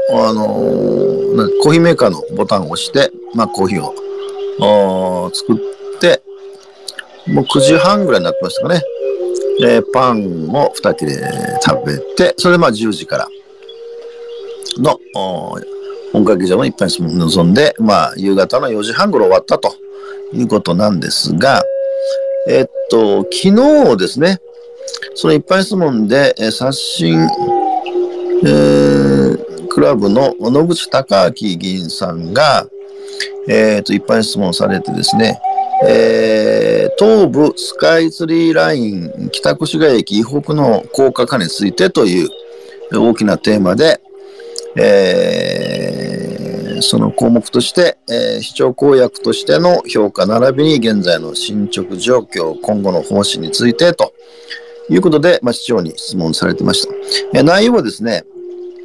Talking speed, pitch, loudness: 265 characters per minute, 270 Hz, -13 LUFS